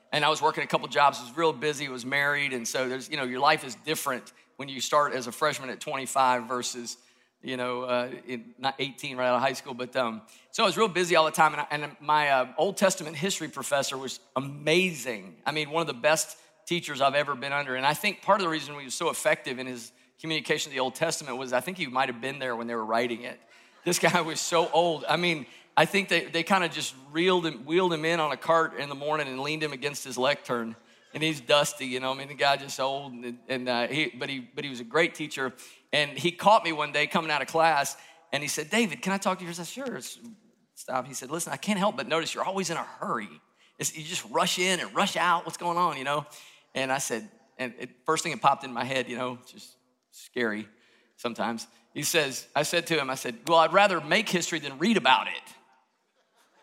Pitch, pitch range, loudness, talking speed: 145 Hz, 130-165 Hz, -27 LUFS, 255 wpm